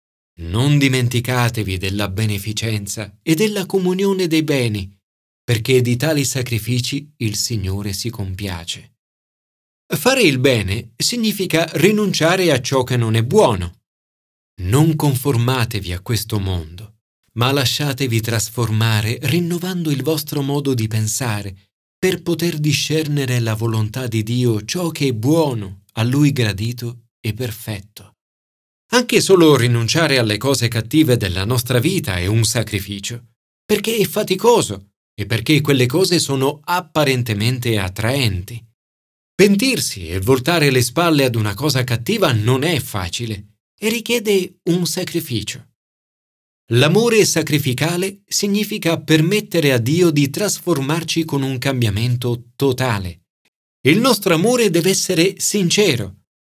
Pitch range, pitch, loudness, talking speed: 110-160 Hz, 125 Hz, -17 LUFS, 120 wpm